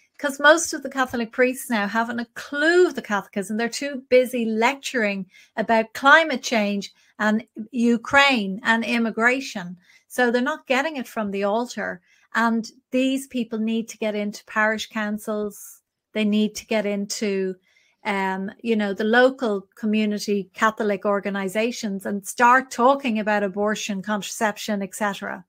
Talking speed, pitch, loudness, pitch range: 145 wpm, 225 Hz, -22 LUFS, 205-245 Hz